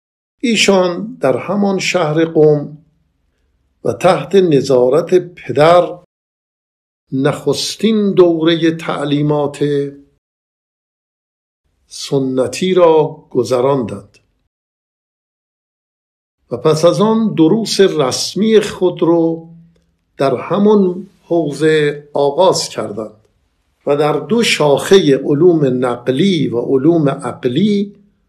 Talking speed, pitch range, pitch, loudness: 80 wpm, 130-180 Hz, 150 Hz, -13 LUFS